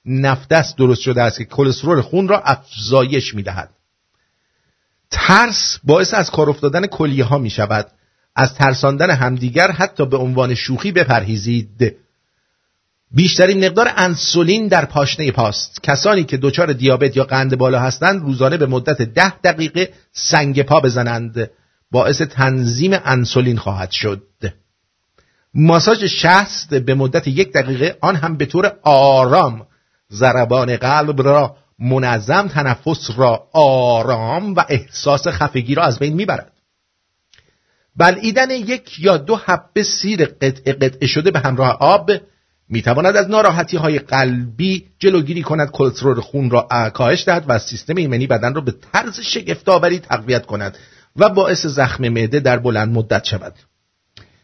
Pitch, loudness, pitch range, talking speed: 135 Hz, -15 LUFS, 125-175 Hz, 135 wpm